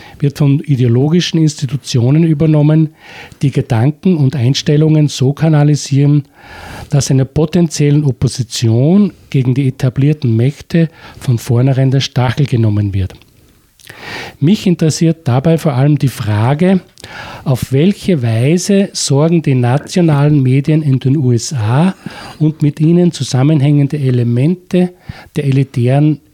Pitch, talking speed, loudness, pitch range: 145 Hz, 110 wpm, -12 LUFS, 130-160 Hz